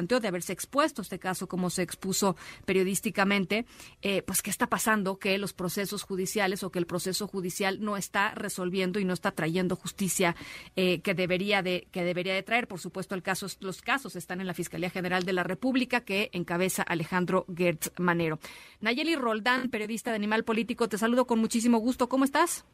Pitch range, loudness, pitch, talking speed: 180-220 Hz, -29 LUFS, 195 Hz, 185 wpm